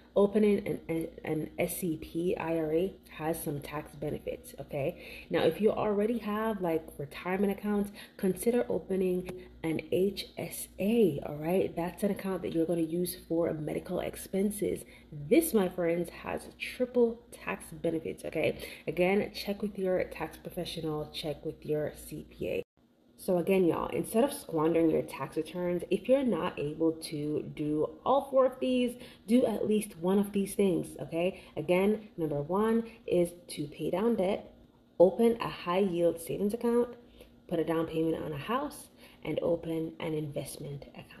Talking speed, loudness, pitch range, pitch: 155 wpm, -32 LUFS, 160-210 Hz, 180 Hz